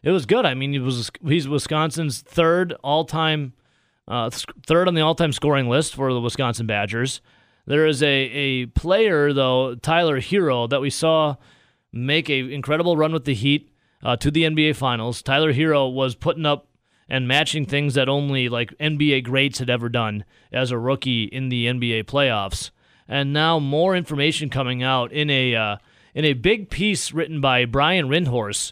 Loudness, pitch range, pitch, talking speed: -21 LUFS, 130-155 Hz, 140 Hz, 180 wpm